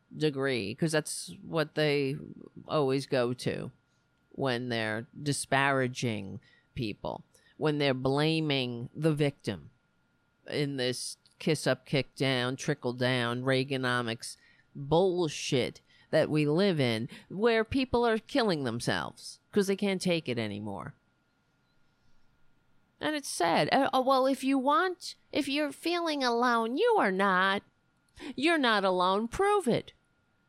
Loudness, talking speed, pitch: -29 LUFS, 120 wpm, 150 Hz